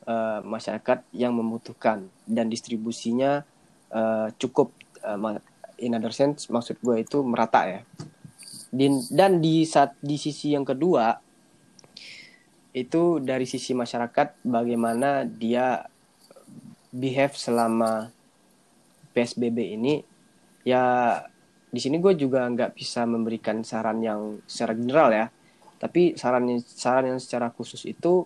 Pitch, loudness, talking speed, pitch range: 125 Hz, -25 LUFS, 115 wpm, 115-140 Hz